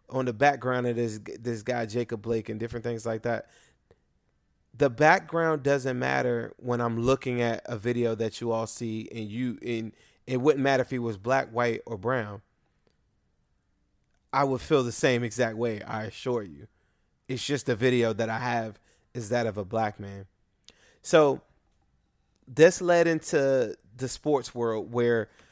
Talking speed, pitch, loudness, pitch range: 170 wpm, 120 Hz, -27 LUFS, 115-130 Hz